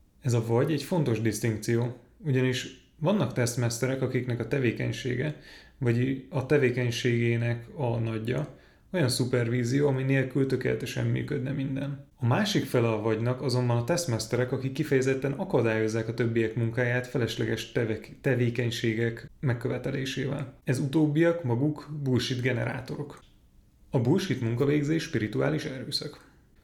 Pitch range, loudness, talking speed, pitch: 115-140 Hz, -28 LUFS, 115 wpm, 125 Hz